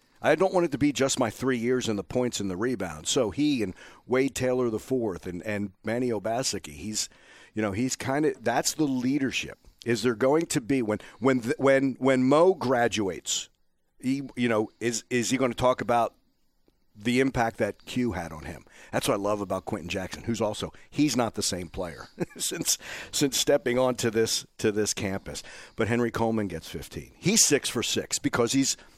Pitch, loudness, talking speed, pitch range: 120 Hz, -27 LUFS, 200 wpm, 105-130 Hz